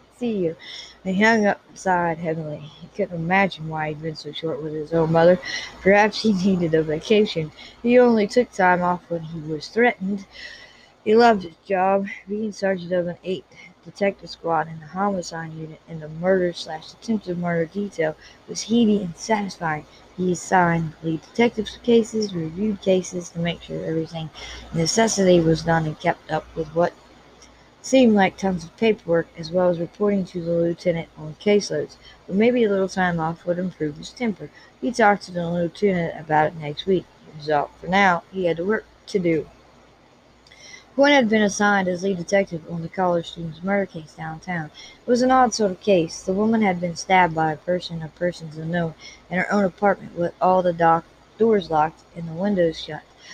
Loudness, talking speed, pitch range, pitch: -22 LUFS, 185 wpm, 165-200 Hz, 180 Hz